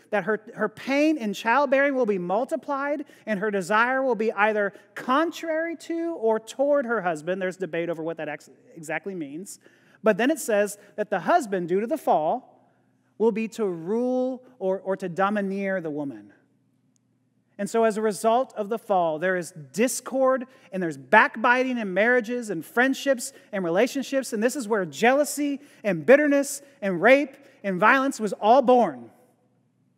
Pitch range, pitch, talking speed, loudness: 190-265 Hz, 225 Hz, 170 wpm, -24 LUFS